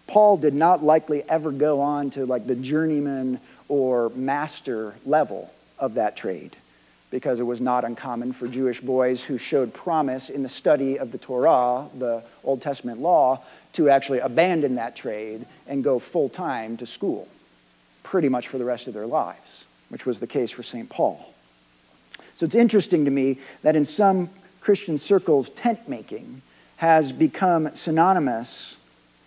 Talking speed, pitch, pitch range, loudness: 160 wpm, 135 Hz, 120-155 Hz, -23 LUFS